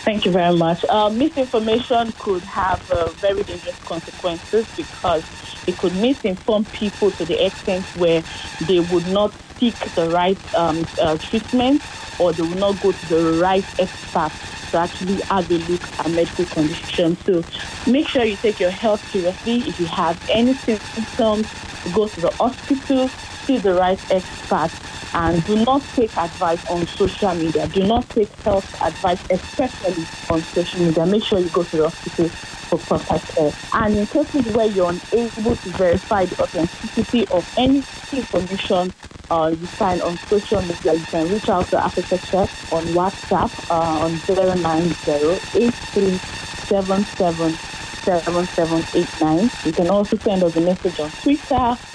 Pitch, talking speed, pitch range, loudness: 185 Hz, 165 wpm, 170-220 Hz, -20 LUFS